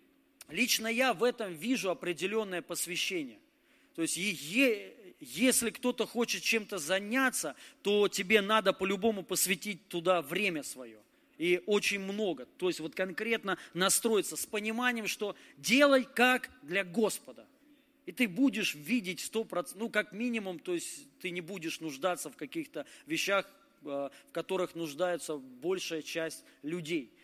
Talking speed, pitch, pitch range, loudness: 135 wpm, 200 Hz, 175-245 Hz, -32 LUFS